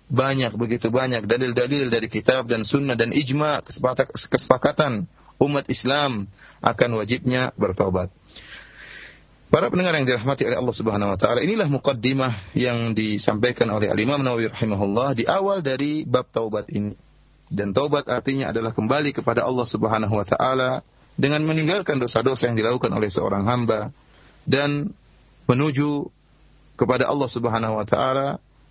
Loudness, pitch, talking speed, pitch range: -22 LUFS, 125 Hz, 135 wpm, 115-140 Hz